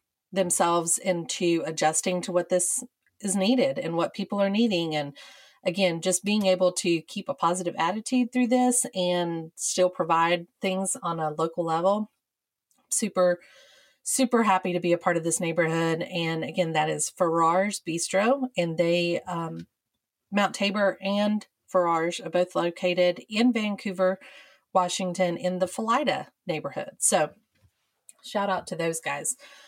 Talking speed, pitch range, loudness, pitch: 145 wpm, 170-205 Hz, -26 LUFS, 180 Hz